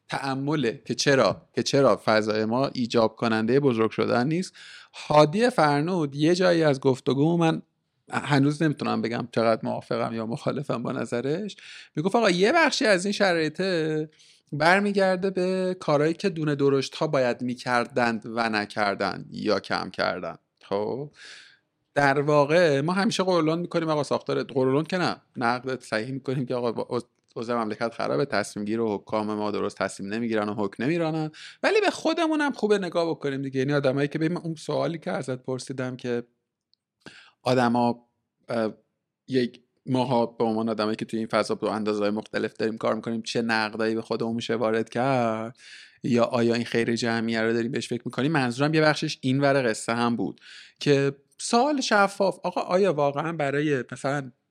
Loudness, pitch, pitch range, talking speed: -25 LUFS, 130 Hz, 115-155 Hz, 160 wpm